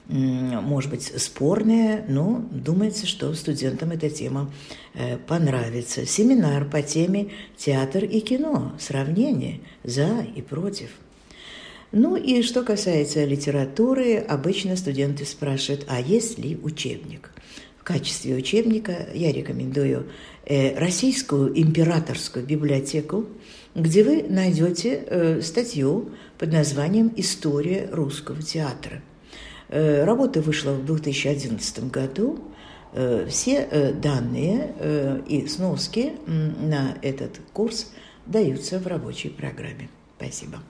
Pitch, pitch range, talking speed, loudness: 155 Hz, 140-210 Hz, 95 wpm, -23 LUFS